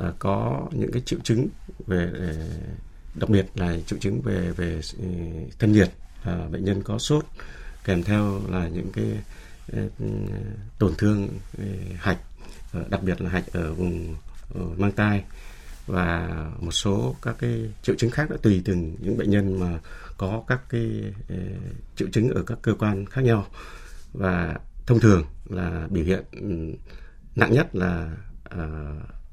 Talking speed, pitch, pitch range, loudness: 160 wpm, 95 Hz, 85-105 Hz, -26 LUFS